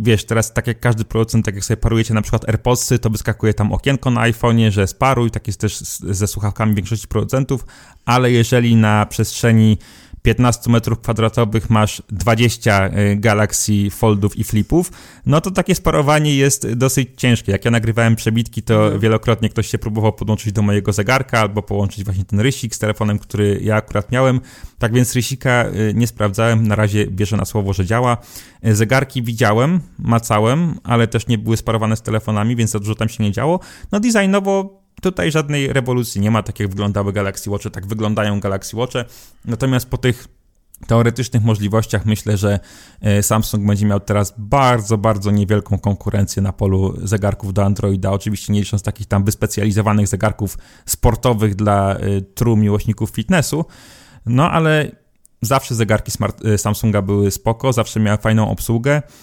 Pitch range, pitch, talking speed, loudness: 105-120 Hz, 110 Hz, 165 wpm, -17 LUFS